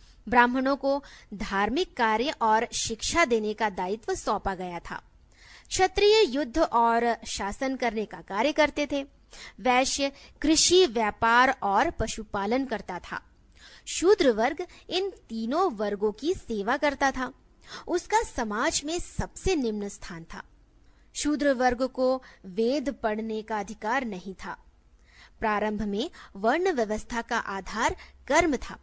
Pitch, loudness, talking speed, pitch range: 245 Hz, -26 LUFS, 125 wpm, 215-295 Hz